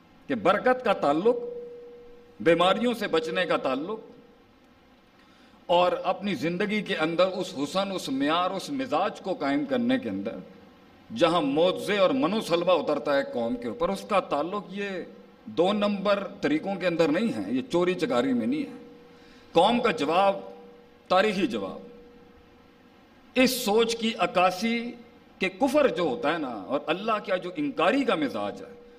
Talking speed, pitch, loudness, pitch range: 155 wpm, 240 Hz, -26 LUFS, 185-260 Hz